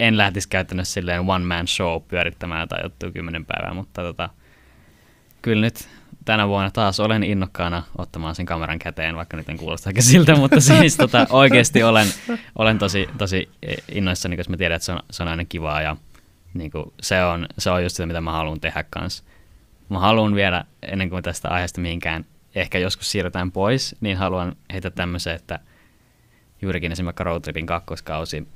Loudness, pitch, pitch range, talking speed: -20 LUFS, 90 Hz, 85-100 Hz, 175 wpm